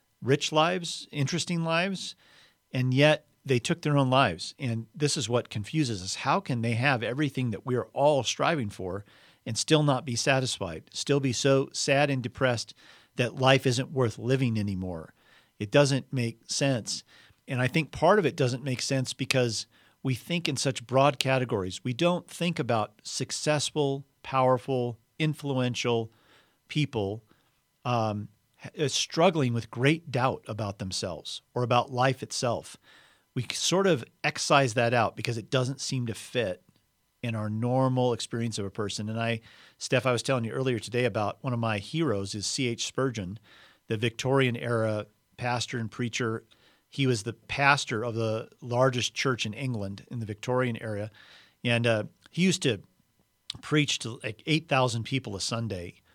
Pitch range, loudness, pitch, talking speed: 115-140 Hz, -28 LUFS, 125 Hz, 165 wpm